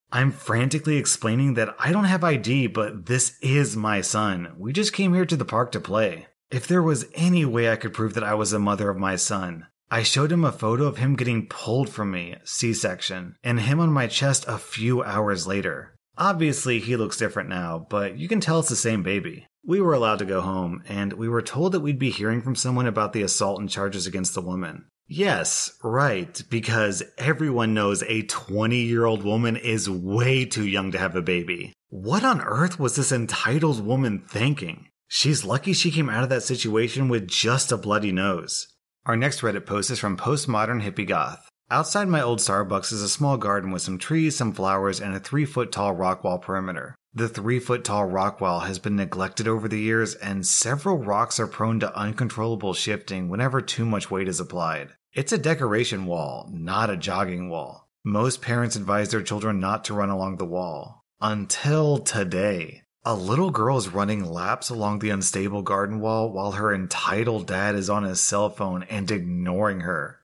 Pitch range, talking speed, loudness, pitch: 100-130 Hz, 200 wpm, -24 LUFS, 110 Hz